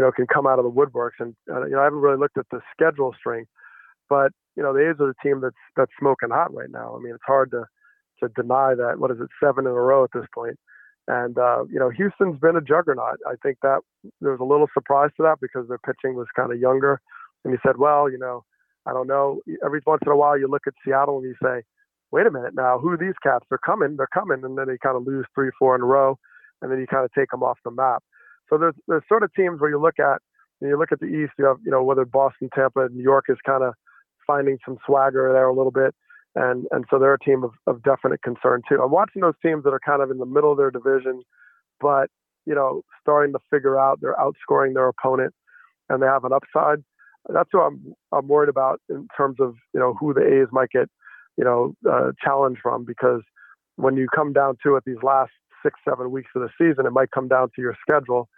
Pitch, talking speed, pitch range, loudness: 135 Hz, 255 wpm, 130-145 Hz, -21 LUFS